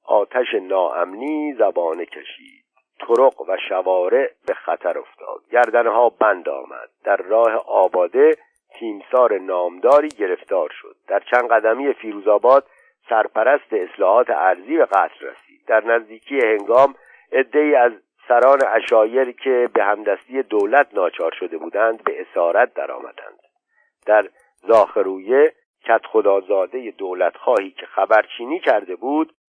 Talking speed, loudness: 115 wpm, -18 LUFS